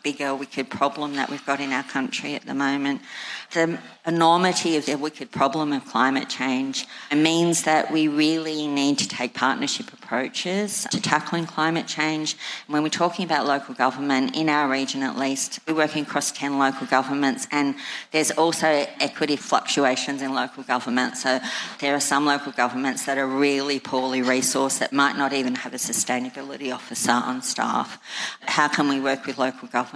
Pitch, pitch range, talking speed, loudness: 140 Hz, 135-155 Hz, 175 wpm, -23 LUFS